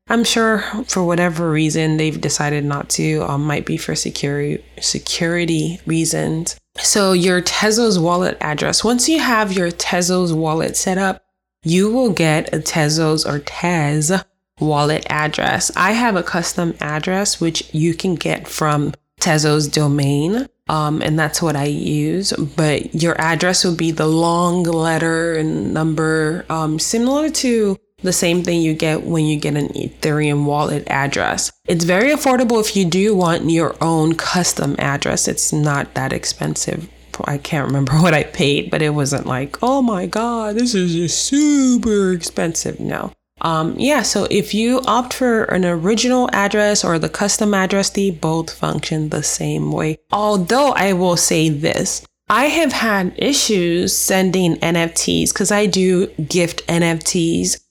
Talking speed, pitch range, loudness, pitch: 155 wpm, 155-200 Hz, -17 LUFS, 170 Hz